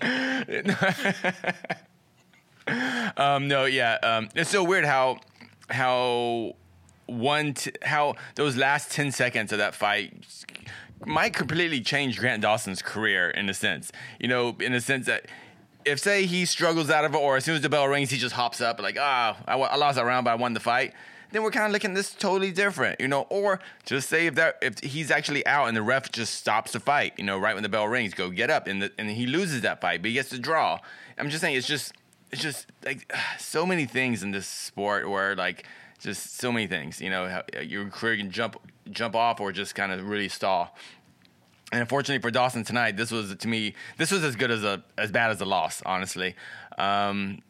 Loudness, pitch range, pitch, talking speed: -26 LUFS, 105-150 Hz, 125 Hz, 215 wpm